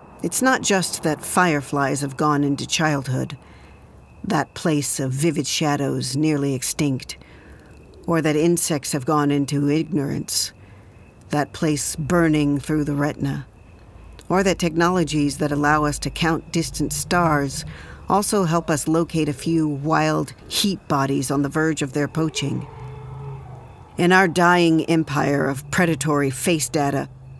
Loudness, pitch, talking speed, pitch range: -21 LUFS, 150 Hz, 135 wpm, 140-165 Hz